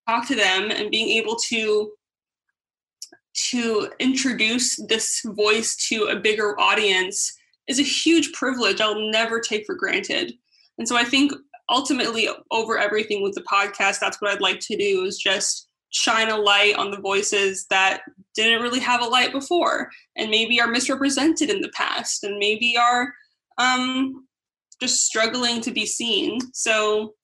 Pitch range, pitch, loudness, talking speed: 210-265 Hz, 230 Hz, -21 LUFS, 160 wpm